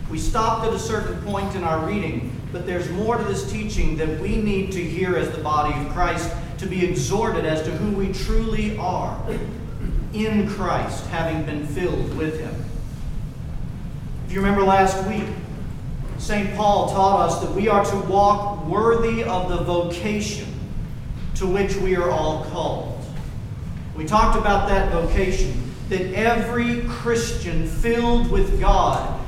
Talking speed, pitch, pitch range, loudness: 155 wpm, 180 Hz, 155-200 Hz, -23 LUFS